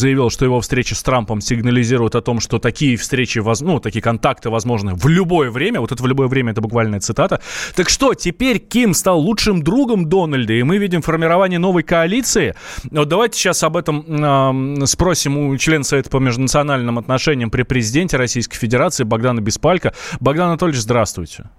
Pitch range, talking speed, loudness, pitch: 120-170 Hz, 180 wpm, -16 LUFS, 135 Hz